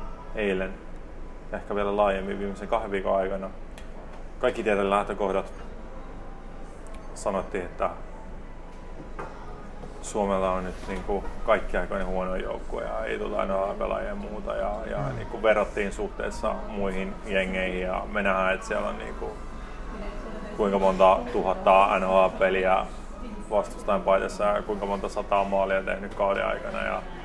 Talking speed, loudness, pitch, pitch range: 130 wpm, -27 LUFS, 95 Hz, 95-100 Hz